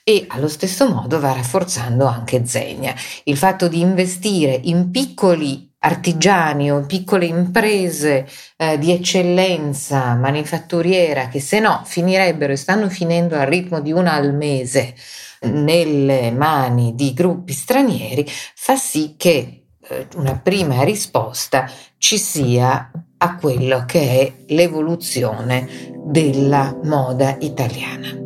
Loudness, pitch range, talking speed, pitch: -17 LUFS, 135-180 Hz, 125 wpm, 155 Hz